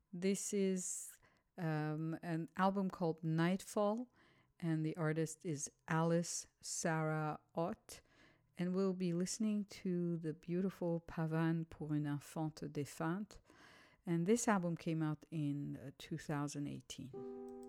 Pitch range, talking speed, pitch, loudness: 155-185 Hz, 115 wpm, 165 Hz, -40 LUFS